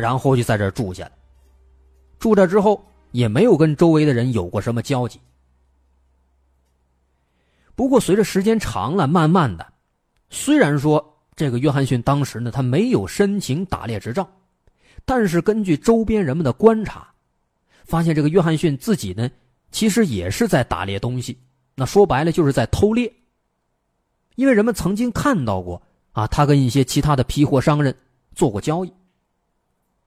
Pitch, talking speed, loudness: 140 Hz, 245 characters per minute, -19 LUFS